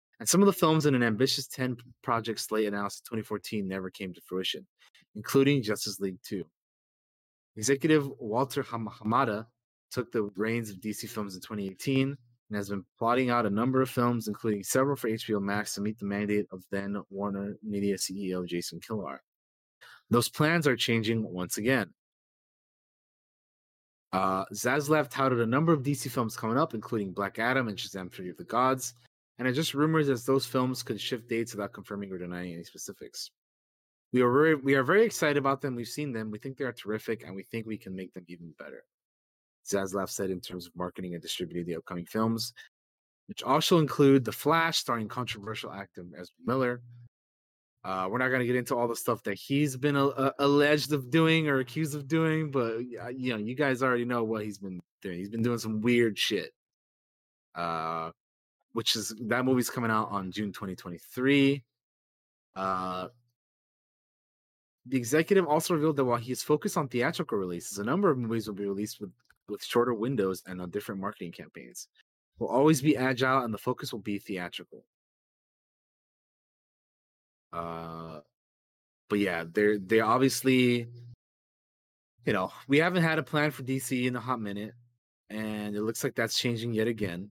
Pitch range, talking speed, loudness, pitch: 100-130 Hz, 180 wpm, -29 LUFS, 115 Hz